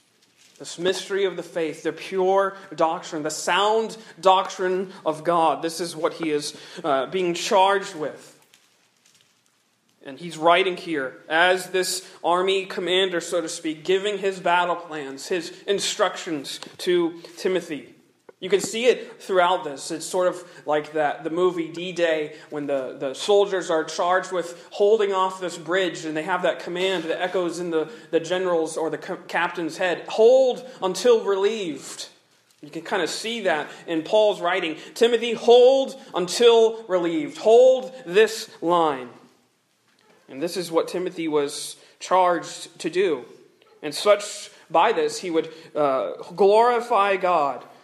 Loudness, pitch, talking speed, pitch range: -22 LUFS, 180 Hz, 150 wpm, 165-205 Hz